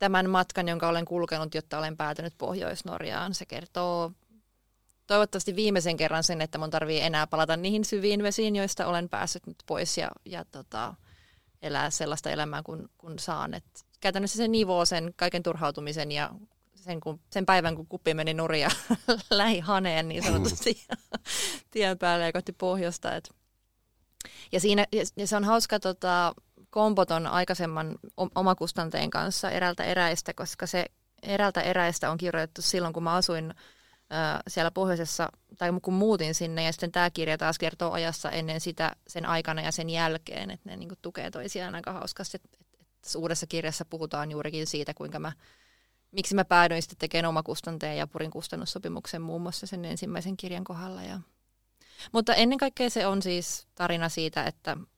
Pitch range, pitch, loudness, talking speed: 160-190 Hz, 170 Hz, -29 LUFS, 160 wpm